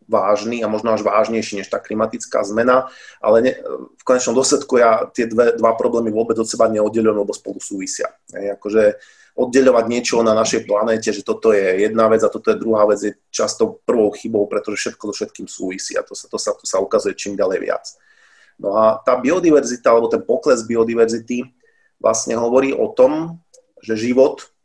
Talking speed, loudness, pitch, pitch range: 185 wpm, -17 LUFS, 115 Hz, 110-140 Hz